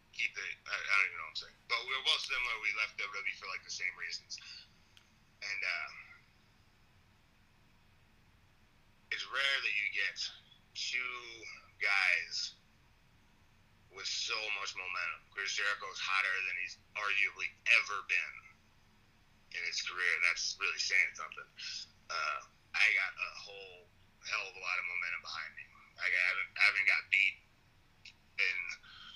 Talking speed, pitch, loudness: 140 wpm, 120 Hz, -34 LUFS